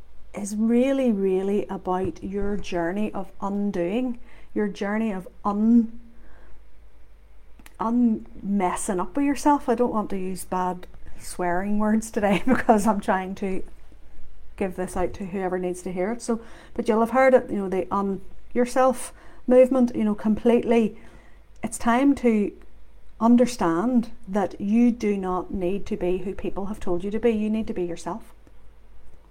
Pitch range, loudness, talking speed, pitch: 185-235 Hz, -24 LUFS, 160 wpm, 210 Hz